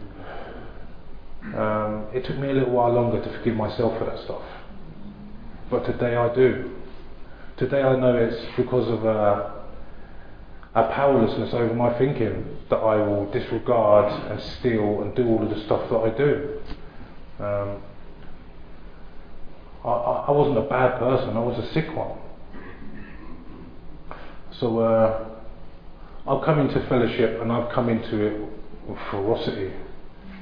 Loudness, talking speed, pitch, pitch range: -23 LUFS, 140 wpm, 110 Hz, 100-125 Hz